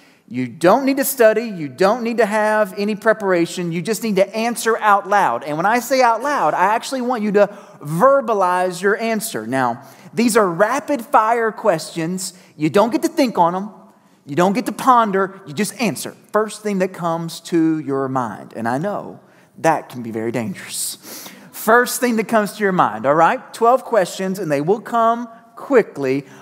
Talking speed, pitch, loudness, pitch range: 195 wpm, 205 Hz, -18 LUFS, 175-230 Hz